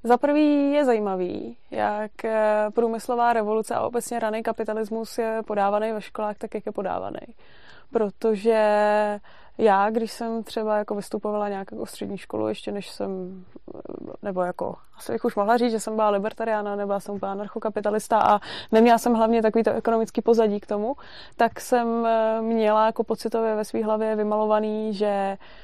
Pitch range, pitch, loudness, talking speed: 210-230 Hz, 220 Hz, -24 LUFS, 155 wpm